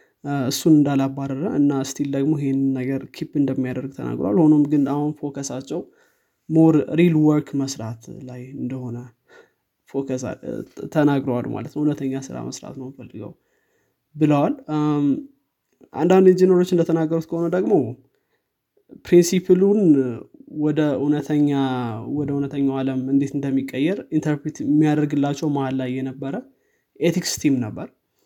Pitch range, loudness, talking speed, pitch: 135-155 Hz, -21 LUFS, 105 wpm, 145 Hz